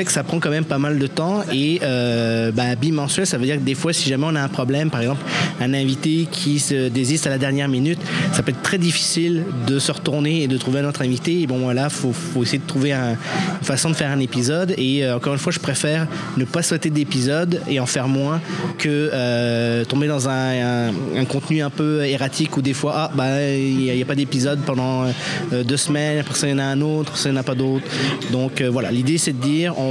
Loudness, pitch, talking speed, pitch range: -20 LUFS, 140 Hz, 260 wpm, 130-155 Hz